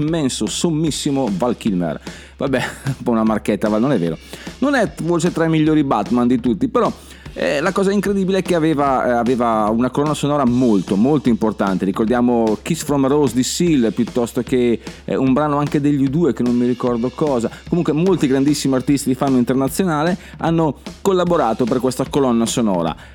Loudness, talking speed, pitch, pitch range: -17 LUFS, 180 wpm, 135 Hz, 120-155 Hz